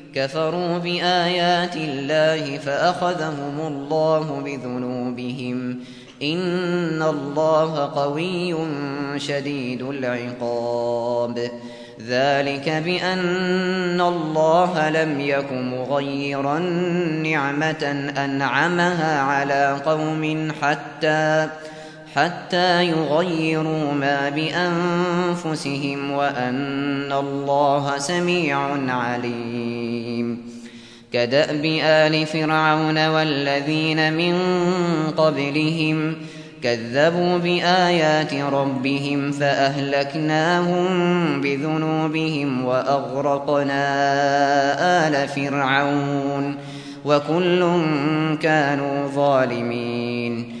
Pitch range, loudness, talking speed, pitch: 140-160 Hz, -21 LUFS, 55 wpm, 145 Hz